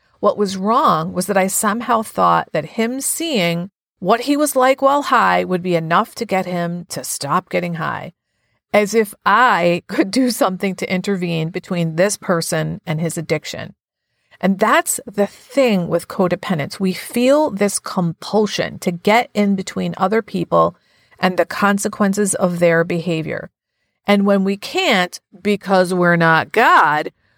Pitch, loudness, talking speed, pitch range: 190 Hz, -17 LUFS, 155 wpm, 175-215 Hz